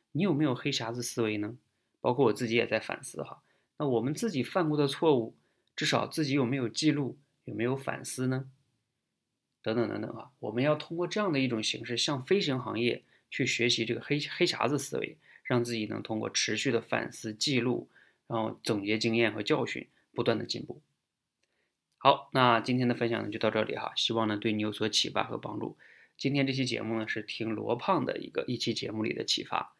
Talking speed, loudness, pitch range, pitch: 305 characters per minute, -30 LUFS, 115-140 Hz, 120 Hz